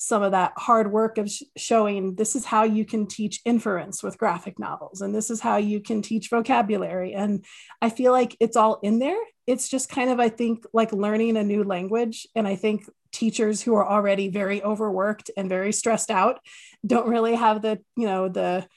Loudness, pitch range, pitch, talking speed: -24 LUFS, 205-230 Hz, 215 Hz, 210 wpm